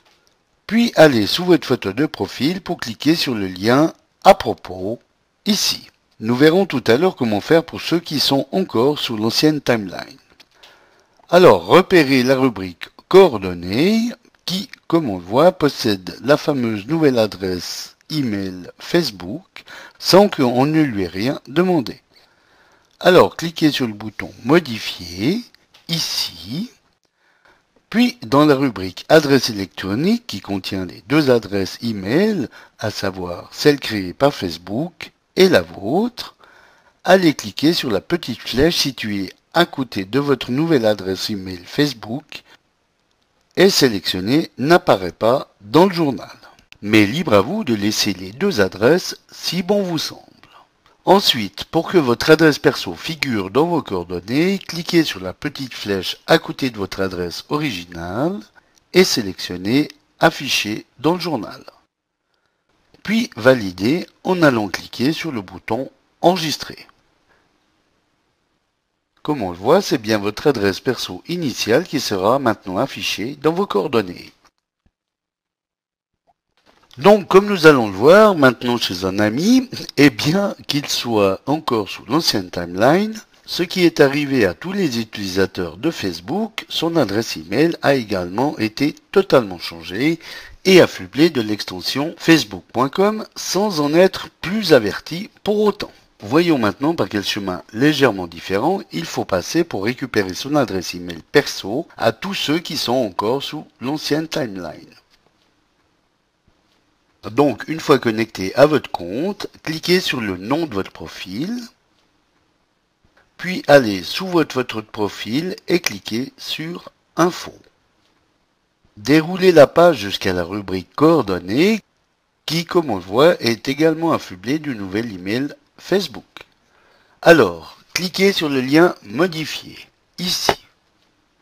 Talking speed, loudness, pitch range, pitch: 135 wpm, -18 LUFS, 105-170 Hz, 140 Hz